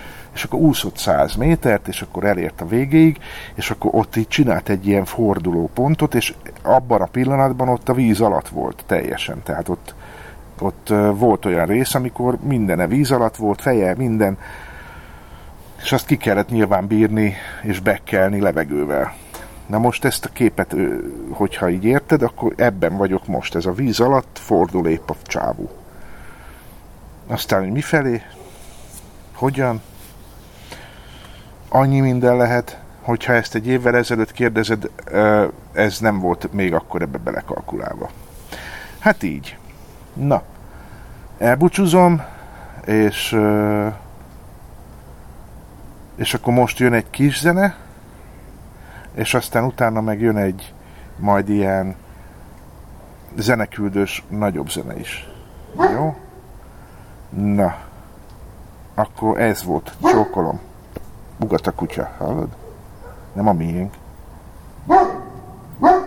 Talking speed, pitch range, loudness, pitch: 115 wpm, 95-125 Hz, -18 LUFS, 110 Hz